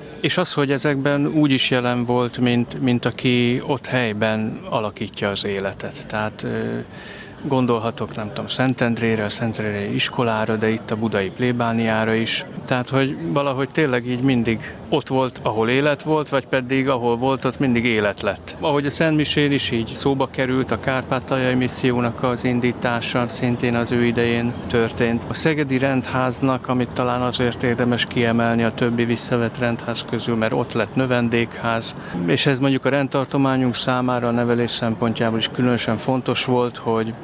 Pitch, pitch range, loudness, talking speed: 125 Hz, 115-135 Hz, -20 LUFS, 155 wpm